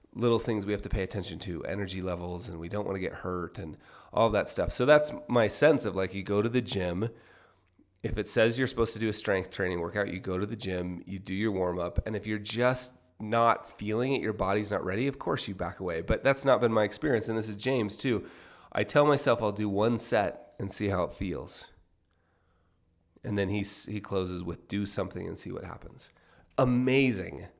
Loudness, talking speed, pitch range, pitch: -30 LUFS, 230 wpm, 90-115 Hz, 105 Hz